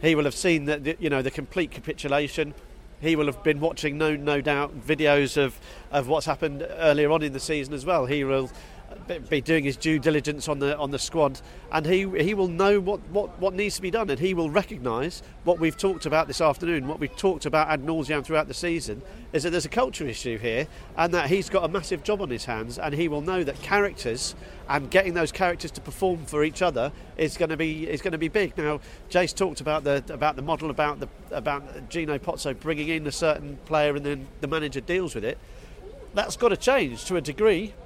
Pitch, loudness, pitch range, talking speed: 155 Hz, -26 LUFS, 145-175 Hz, 230 wpm